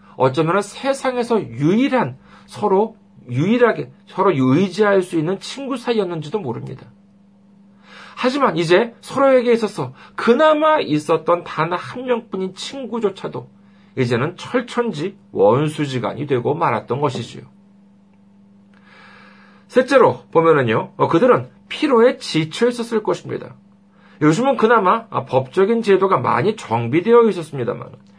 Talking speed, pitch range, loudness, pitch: 275 characters per minute, 170-235 Hz, -18 LUFS, 200 Hz